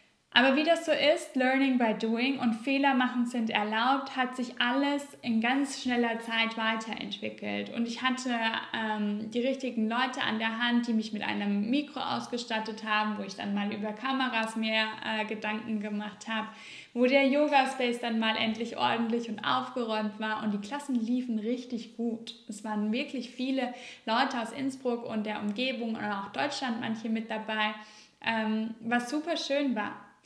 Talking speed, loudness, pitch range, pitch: 170 wpm, -30 LUFS, 220-255 Hz, 230 Hz